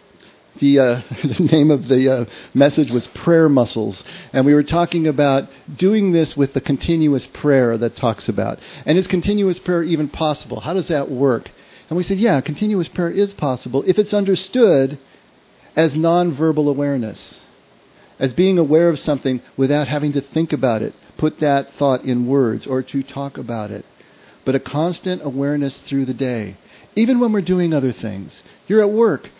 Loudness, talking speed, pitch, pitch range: -18 LUFS, 175 wpm, 145 Hz, 130-170 Hz